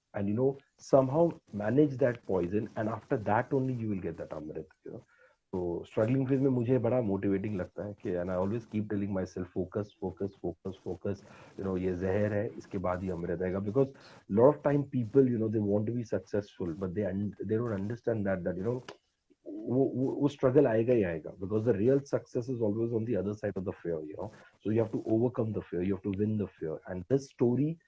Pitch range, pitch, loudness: 95-125 Hz, 105 Hz, -31 LUFS